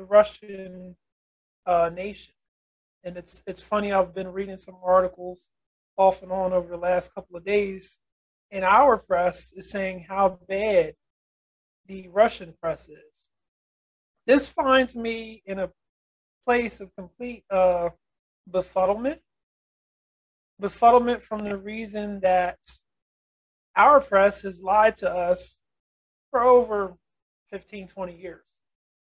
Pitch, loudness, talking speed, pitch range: 190 Hz, -23 LUFS, 120 wpm, 180-210 Hz